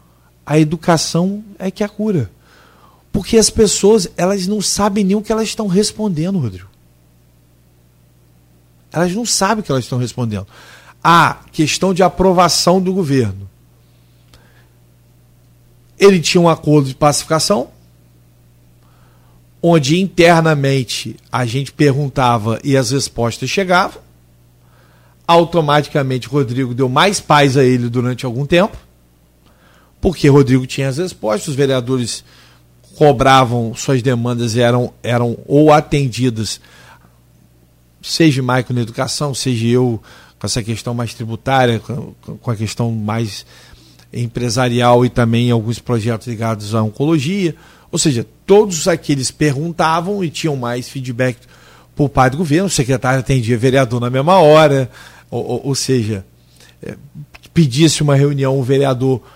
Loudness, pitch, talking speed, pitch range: -15 LUFS, 130 Hz, 130 wpm, 105-155 Hz